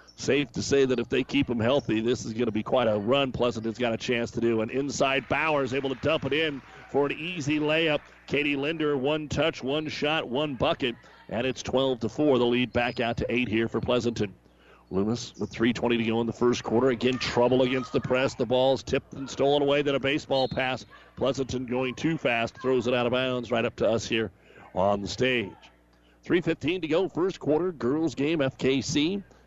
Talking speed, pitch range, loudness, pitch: 215 wpm, 115-140 Hz, -27 LUFS, 130 Hz